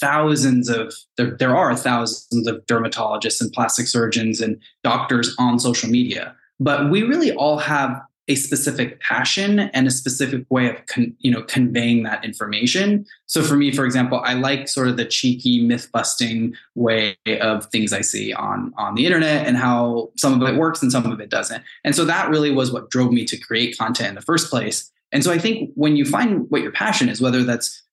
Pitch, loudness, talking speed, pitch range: 125 Hz, -19 LUFS, 205 wpm, 120-140 Hz